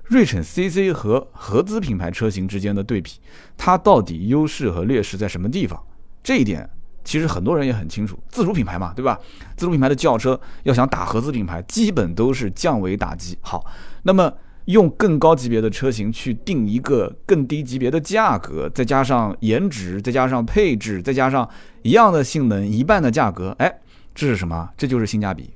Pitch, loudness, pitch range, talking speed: 125 Hz, -19 LUFS, 105-160 Hz, 295 characters per minute